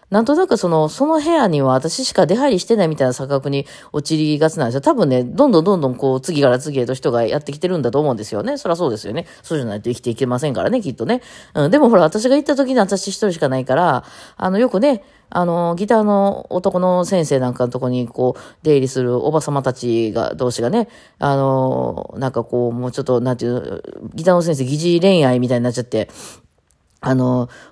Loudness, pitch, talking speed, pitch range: -17 LUFS, 145 Hz, 450 characters per minute, 125-195 Hz